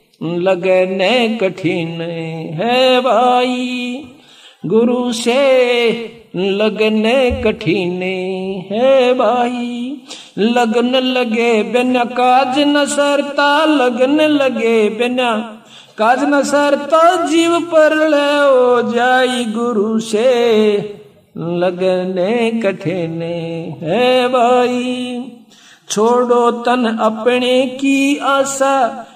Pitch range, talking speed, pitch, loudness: 215-255 Hz, 75 wpm, 240 Hz, -14 LUFS